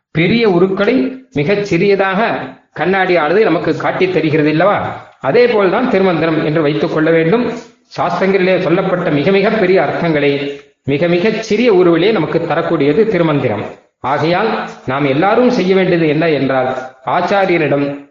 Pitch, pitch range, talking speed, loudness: 175 Hz, 145-195 Hz, 125 wpm, -13 LUFS